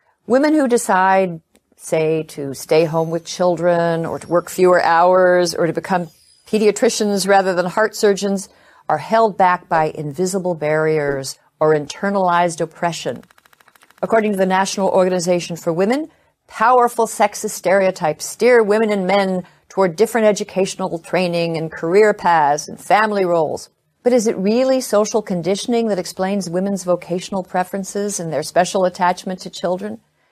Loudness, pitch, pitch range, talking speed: -17 LUFS, 185 Hz, 170-210 Hz, 140 wpm